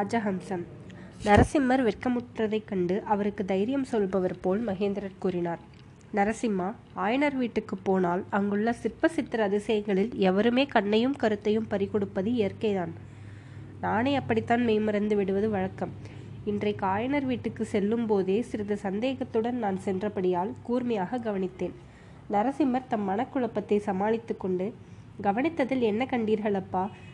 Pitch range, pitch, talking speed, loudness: 195-235 Hz, 210 Hz, 100 wpm, -28 LUFS